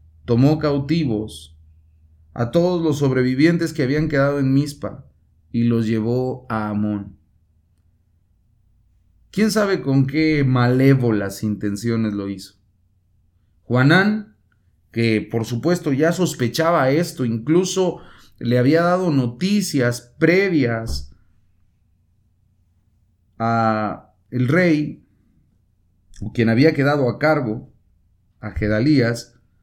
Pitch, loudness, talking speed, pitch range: 115 Hz, -19 LUFS, 95 wpm, 95-145 Hz